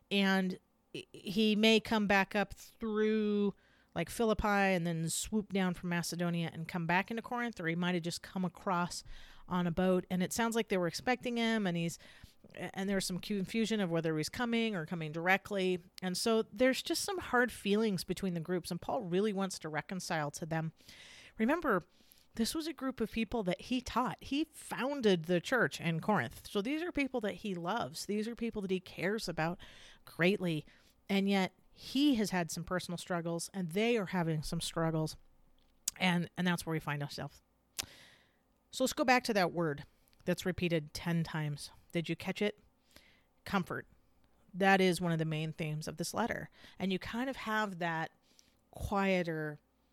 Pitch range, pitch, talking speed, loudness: 170-215 Hz, 185 Hz, 185 wpm, -35 LUFS